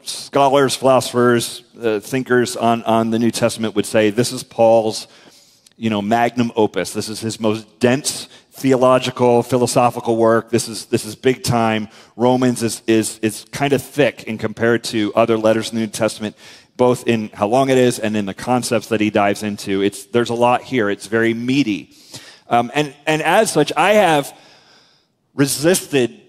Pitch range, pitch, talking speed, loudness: 110-125 Hz, 115 Hz, 180 wpm, -17 LUFS